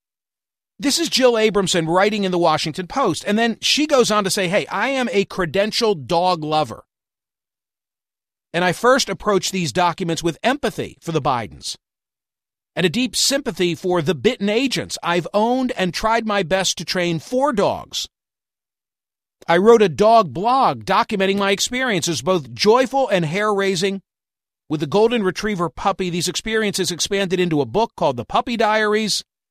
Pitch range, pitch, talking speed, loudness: 180-225 Hz, 200 Hz, 165 wpm, -19 LUFS